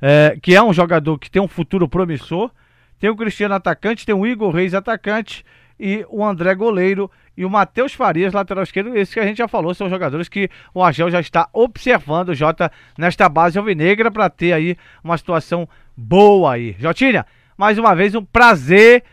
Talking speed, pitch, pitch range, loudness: 190 wpm, 190 Hz, 170-210 Hz, -15 LUFS